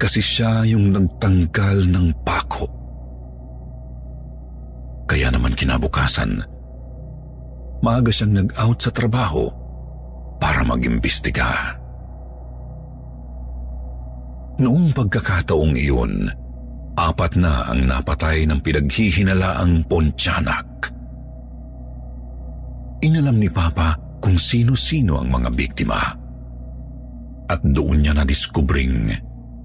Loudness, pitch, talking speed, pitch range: -19 LUFS, 70 Hz, 75 wpm, 60-90 Hz